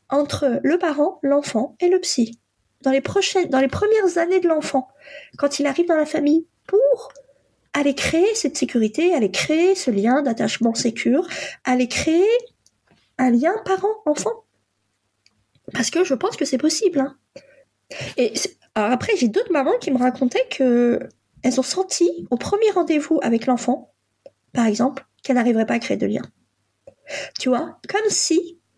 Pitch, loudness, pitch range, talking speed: 285 Hz, -20 LUFS, 250-345 Hz, 160 wpm